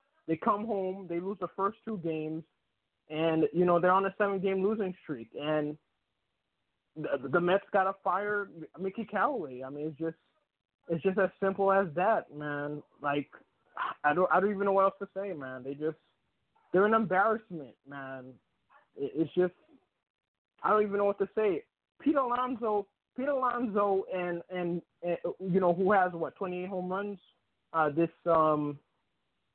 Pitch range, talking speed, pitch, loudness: 155-200 Hz, 175 wpm, 180 Hz, -31 LUFS